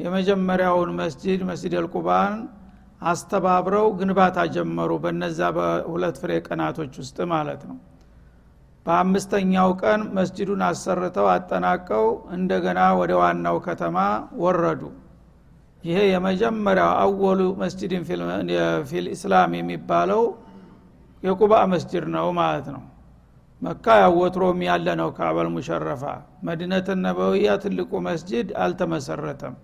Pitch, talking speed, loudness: 180 Hz, 90 wpm, -22 LUFS